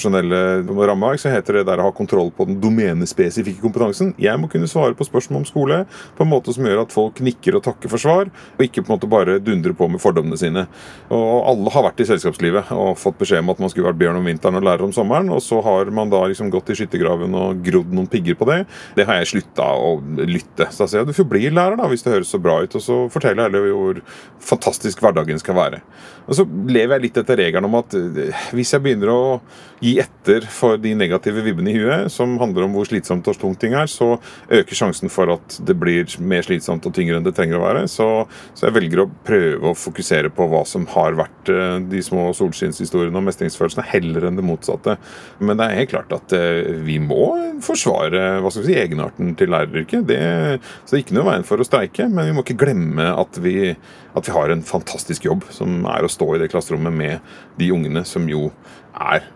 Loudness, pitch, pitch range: -18 LUFS, 105 Hz, 90-135 Hz